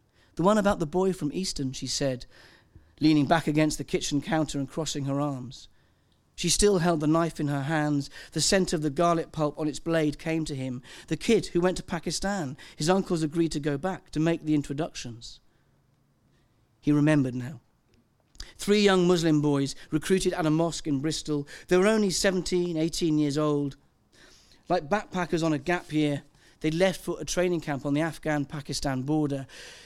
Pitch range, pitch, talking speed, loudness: 145-175 Hz, 155 Hz, 185 wpm, -27 LUFS